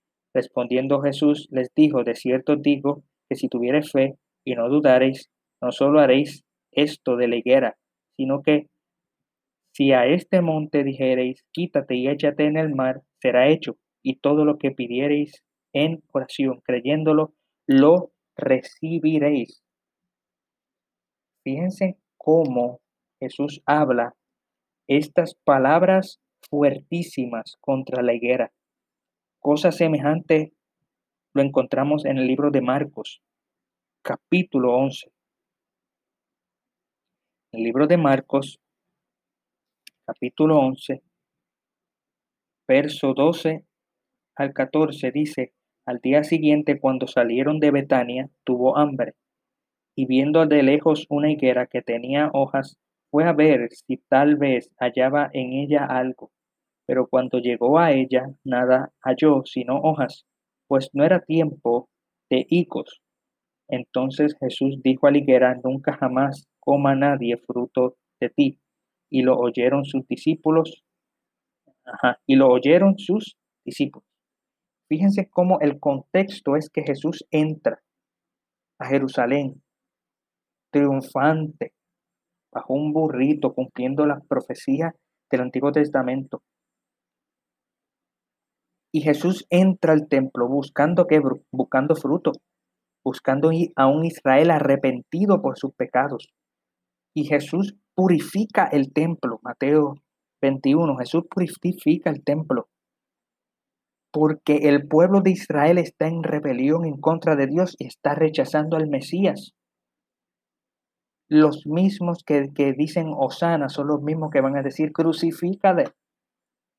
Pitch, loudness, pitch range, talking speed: 145 Hz, -21 LUFS, 130-155 Hz, 115 wpm